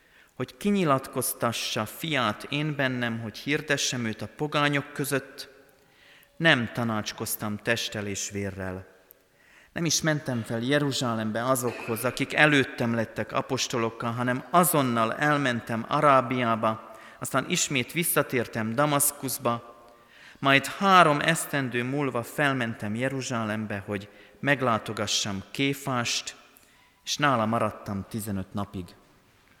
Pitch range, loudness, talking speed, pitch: 110-140 Hz, -26 LUFS, 95 wpm, 120 Hz